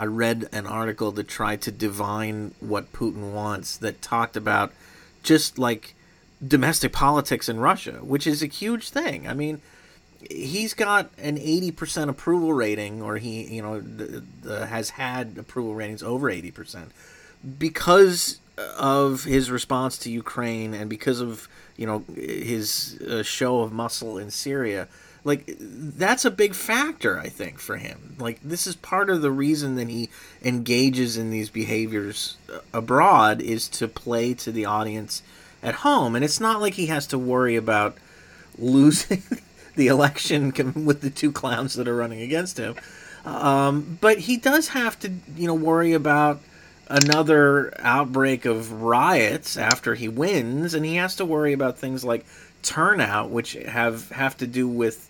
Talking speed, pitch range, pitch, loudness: 160 wpm, 115-155 Hz, 130 Hz, -23 LUFS